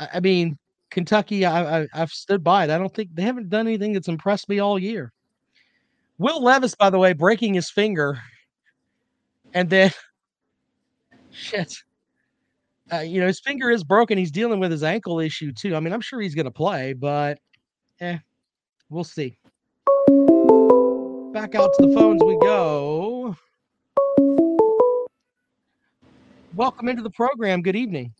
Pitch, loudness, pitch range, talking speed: 200 Hz, -20 LUFS, 165-250 Hz, 150 wpm